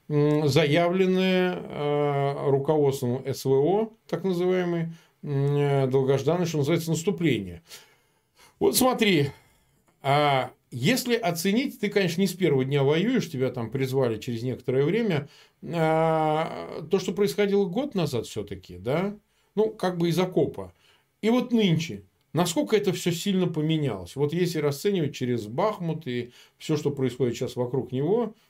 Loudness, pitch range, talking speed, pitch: -25 LUFS, 135-185 Hz, 130 wpm, 155 Hz